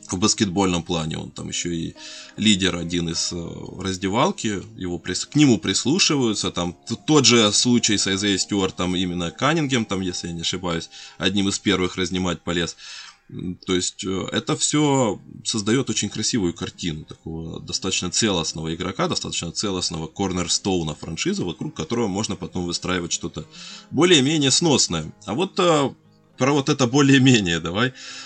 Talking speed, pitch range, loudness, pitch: 140 wpm, 85-120 Hz, -21 LUFS, 95 Hz